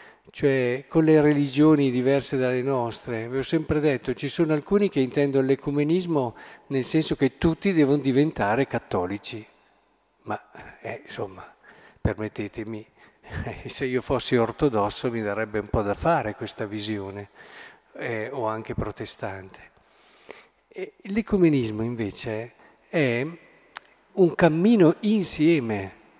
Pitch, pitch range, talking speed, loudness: 135 Hz, 110-160 Hz, 115 wpm, -24 LUFS